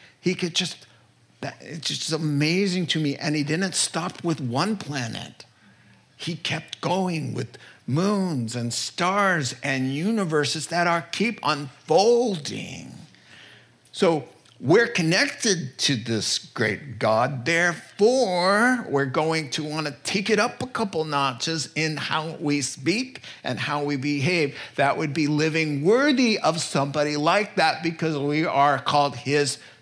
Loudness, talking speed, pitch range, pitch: -23 LUFS, 140 wpm, 140-180 Hz, 155 Hz